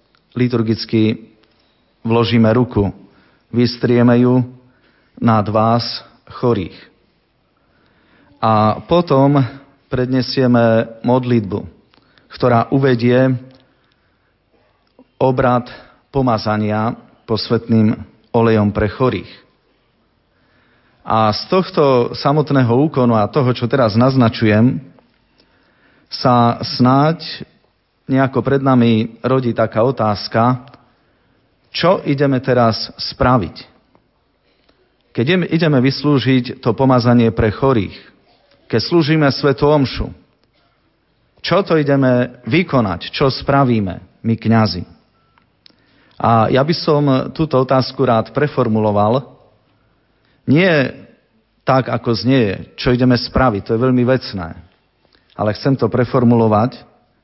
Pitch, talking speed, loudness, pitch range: 120 Hz, 90 wpm, -15 LUFS, 110-130 Hz